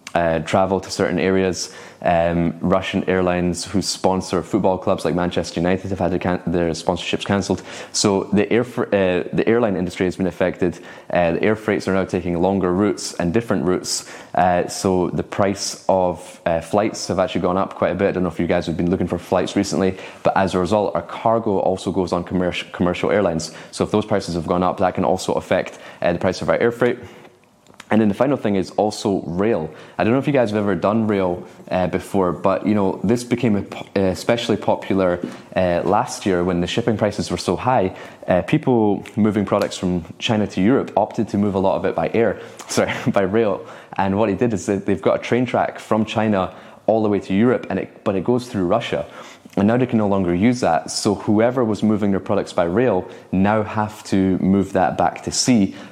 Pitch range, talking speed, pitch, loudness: 90-105 Hz, 220 wpm, 95 Hz, -20 LUFS